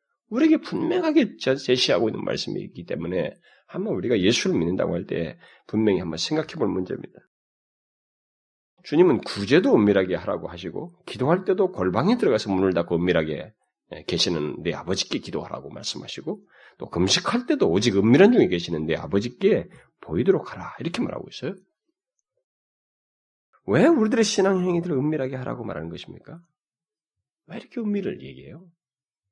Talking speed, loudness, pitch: 360 characters per minute, -23 LUFS, 155 Hz